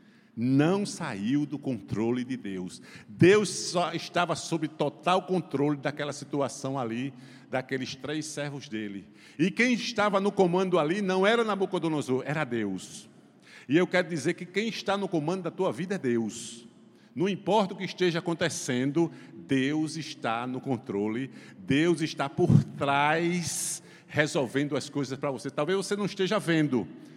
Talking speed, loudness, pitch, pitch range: 150 wpm, -28 LUFS, 155 Hz, 135-180 Hz